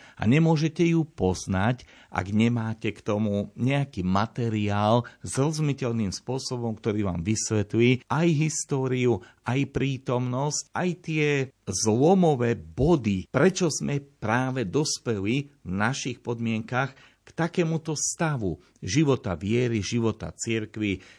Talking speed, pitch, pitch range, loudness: 110 wpm, 120 Hz, 110-145 Hz, -26 LUFS